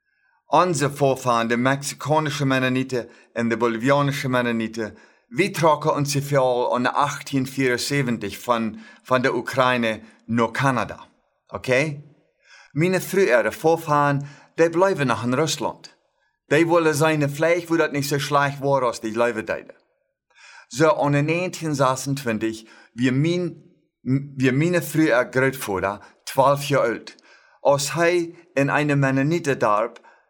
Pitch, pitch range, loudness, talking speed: 140 Hz, 125-155 Hz, -21 LUFS, 120 wpm